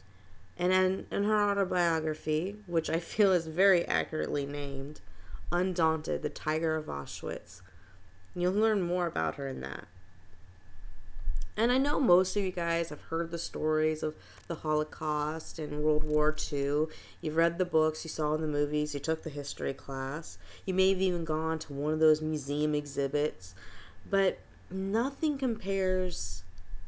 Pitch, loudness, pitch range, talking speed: 155 Hz, -31 LUFS, 140-180 Hz, 155 wpm